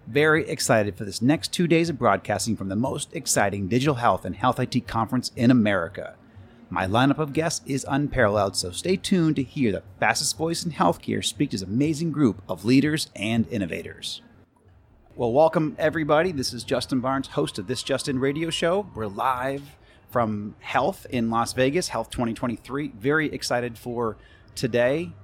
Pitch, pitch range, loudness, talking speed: 125 Hz, 110-145 Hz, -24 LUFS, 170 wpm